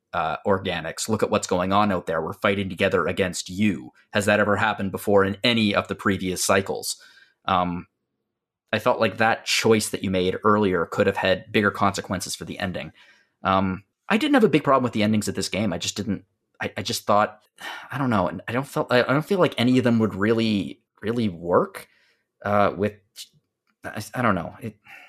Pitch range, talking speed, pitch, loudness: 95-115 Hz, 210 wpm, 105 Hz, -23 LUFS